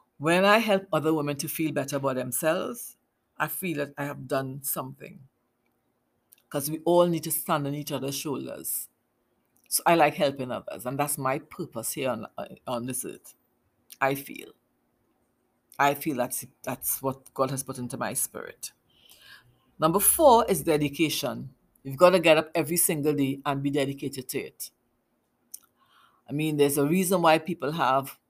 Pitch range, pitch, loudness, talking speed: 135-160 Hz, 145 Hz, -26 LUFS, 170 wpm